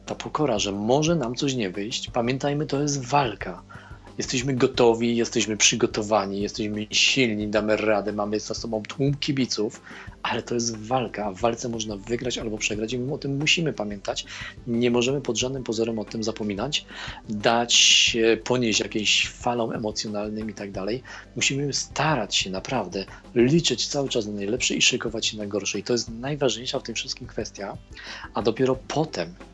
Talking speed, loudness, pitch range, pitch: 170 wpm, -24 LUFS, 105-125 Hz, 115 Hz